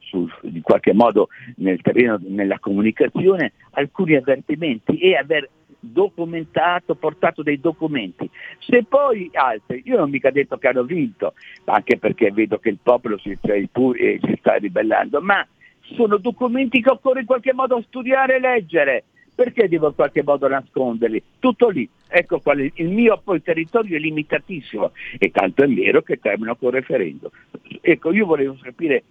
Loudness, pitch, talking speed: -19 LUFS, 165 Hz, 155 wpm